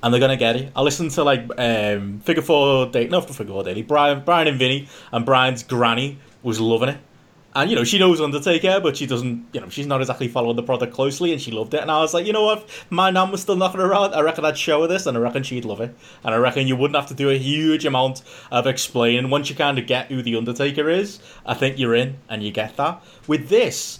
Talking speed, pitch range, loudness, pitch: 270 wpm, 125-155 Hz, -20 LUFS, 135 Hz